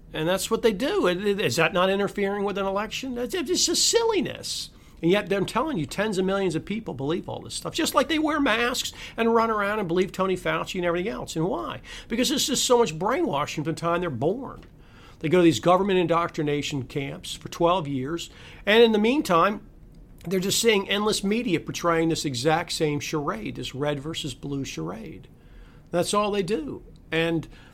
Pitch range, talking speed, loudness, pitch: 160-215 Hz, 200 wpm, -24 LUFS, 180 Hz